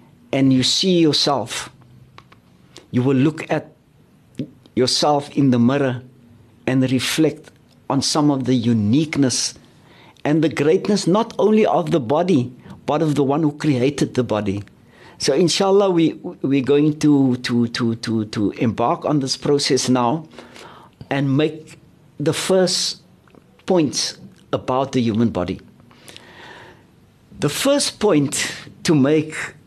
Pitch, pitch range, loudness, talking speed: 140 Hz, 125-155 Hz, -19 LUFS, 130 wpm